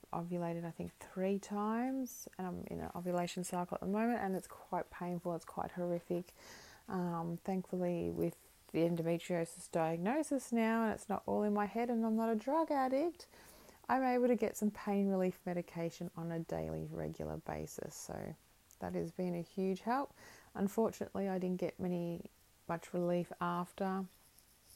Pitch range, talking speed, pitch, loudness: 170-215 Hz, 165 wpm, 180 Hz, -39 LUFS